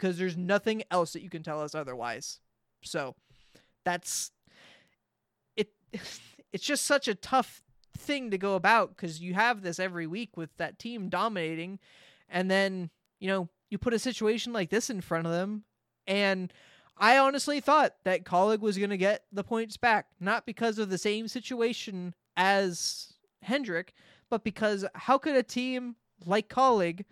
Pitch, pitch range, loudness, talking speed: 200 Hz, 180-230 Hz, -29 LUFS, 165 wpm